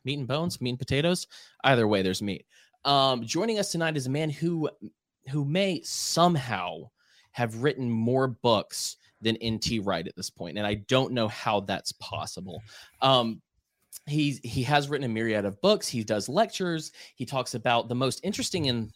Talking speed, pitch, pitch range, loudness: 180 wpm, 130 Hz, 110-150 Hz, -27 LUFS